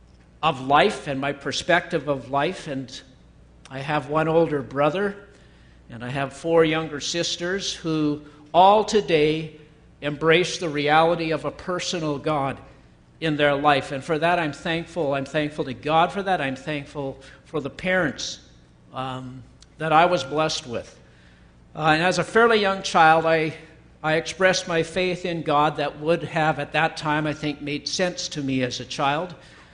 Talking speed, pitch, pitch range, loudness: 165 wpm, 155 Hz, 140-165 Hz, -23 LUFS